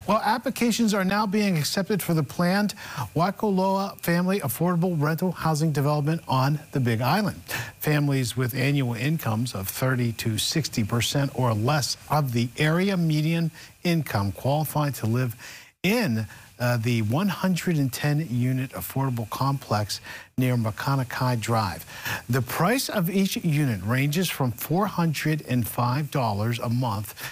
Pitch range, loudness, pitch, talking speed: 120-170 Hz, -25 LUFS, 140 Hz, 125 wpm